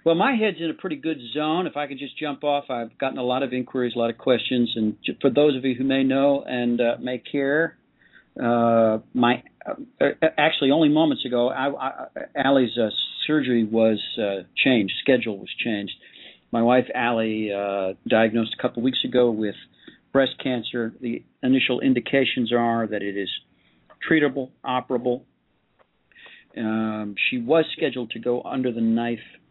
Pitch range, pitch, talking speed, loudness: 115-140 Hz, 125 Hz, 175 wpm, -23 LUFS